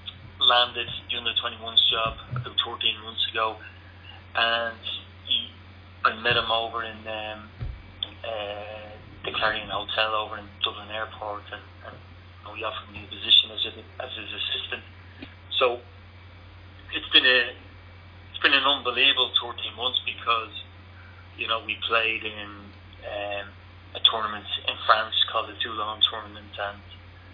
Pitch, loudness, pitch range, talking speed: 100 Hz, -24 LUFS, 95-110 Hz, 135 wpm